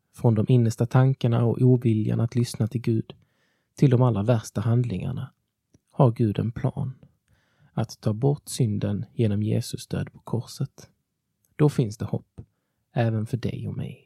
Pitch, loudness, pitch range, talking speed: 120 Hz, -25 LUFS, 110-135 Hz, 160 wpm